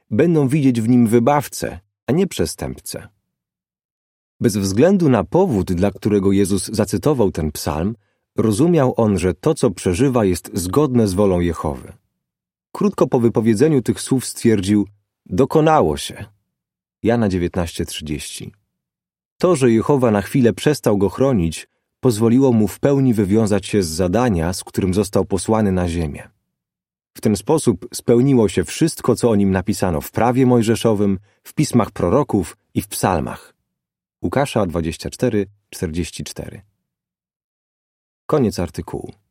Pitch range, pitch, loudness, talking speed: 95-125 Hz, 105 Hz, -18 LUFS, 130 wpm